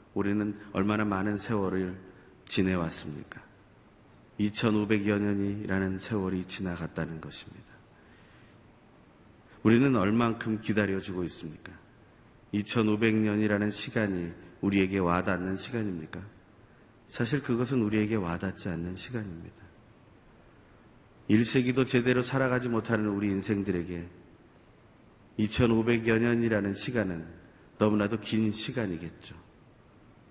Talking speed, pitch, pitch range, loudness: 250 characters per minute, 105 Hz, 95-115 Hz, -29 LUFS